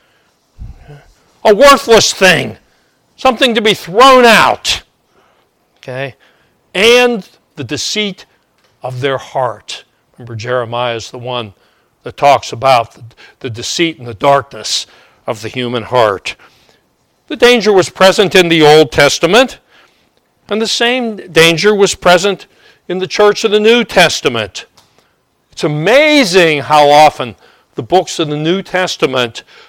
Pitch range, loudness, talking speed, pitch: 130-215 Hz, -10 LUFS, 130 wpm, 170 Hz